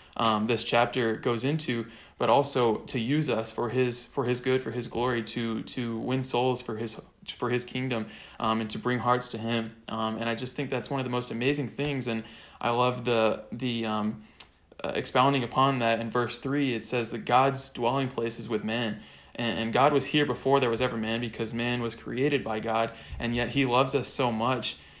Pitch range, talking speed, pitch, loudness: 115-130 Hz, 220 wpm, 120 Hz, -28 LUFS